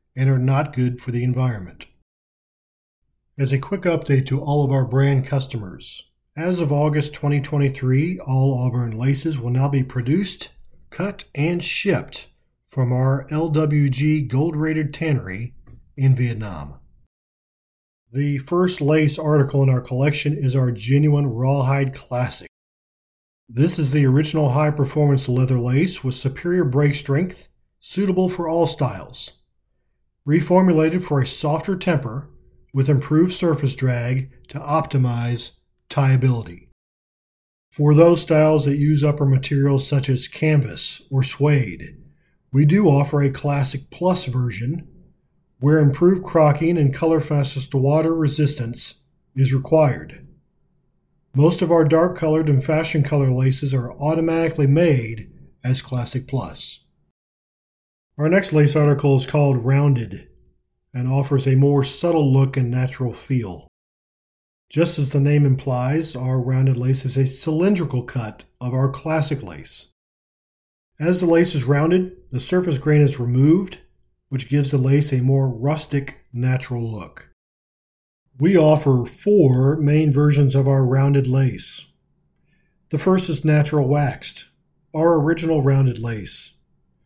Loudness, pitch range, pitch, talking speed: -19 LUFS, 130-155 Hz, 140 Hz, 130 wpm